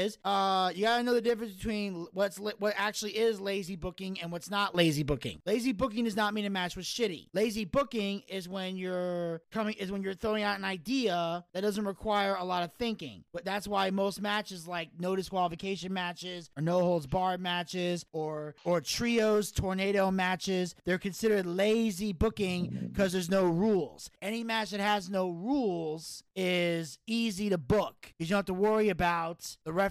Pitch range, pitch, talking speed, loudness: 180-210 Hz, 195 Hz, 185 wpm, -32 LUFS